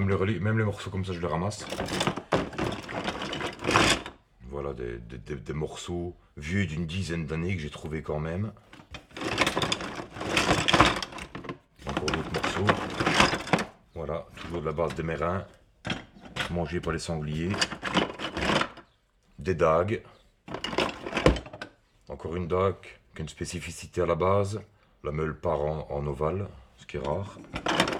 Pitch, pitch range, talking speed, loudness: 85 Hz, 80-95 Hz, 120 wpm, -29 LUFS